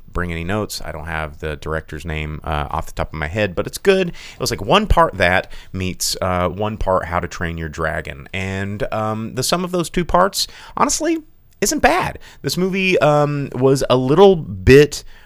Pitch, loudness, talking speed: 100 Hz, -18 LUFS, 205 wpm